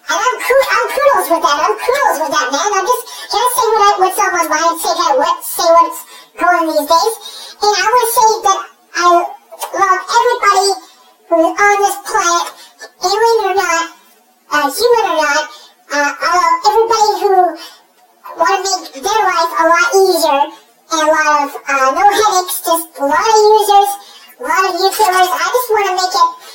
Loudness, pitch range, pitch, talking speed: -12 LUFS, 335-430 Hz, 380 Hz, 190 wpm